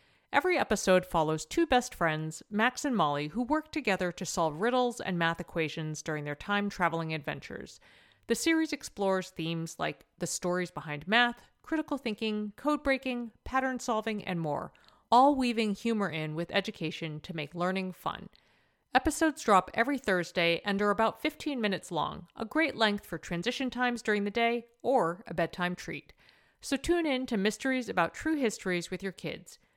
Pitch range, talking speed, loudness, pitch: 170-250 Hz, 170 wpm, -31 LUFS, 205 Hz